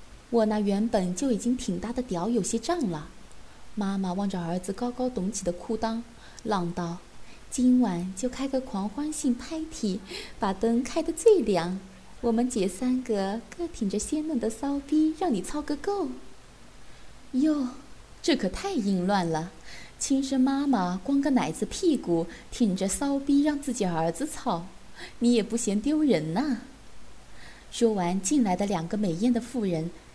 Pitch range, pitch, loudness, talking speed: 195-270 Hz, 230 Hz, -28 LUFS, 220 characters per minute